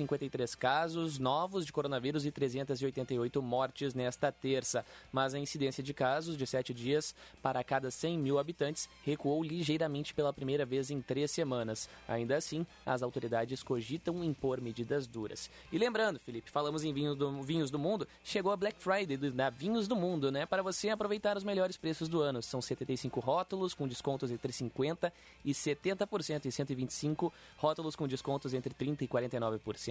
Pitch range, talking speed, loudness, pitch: 130-160 Hz, 170 wpm, -36 LUFS, 140 Hz